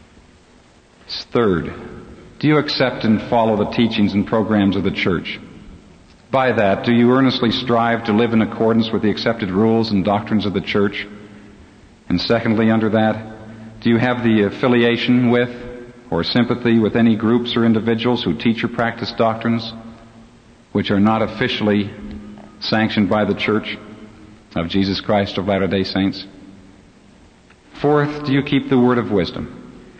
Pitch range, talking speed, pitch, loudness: 105-120 Hz, 150 wpm, 110 Hz, -18 LUFS